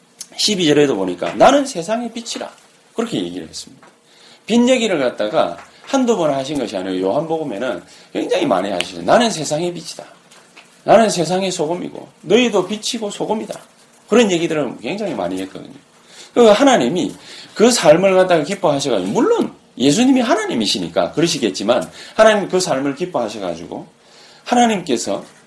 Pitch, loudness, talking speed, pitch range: 205 Hz, -16 LUFS, 360 characters per minute, 165-235 Hz